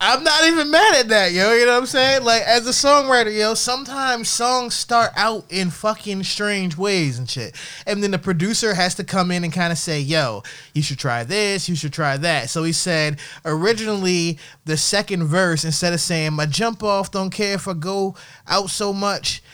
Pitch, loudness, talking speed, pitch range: 190 Hz, -18 LUFS, 210 wpm, 160-220 Hz